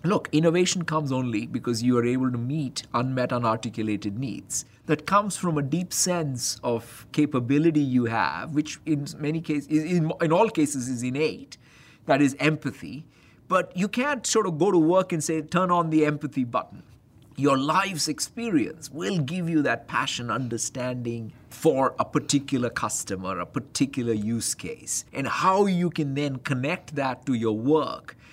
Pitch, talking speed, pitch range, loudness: 145 Hz, 165 wpm, 125-160 Hz, -25 LUFS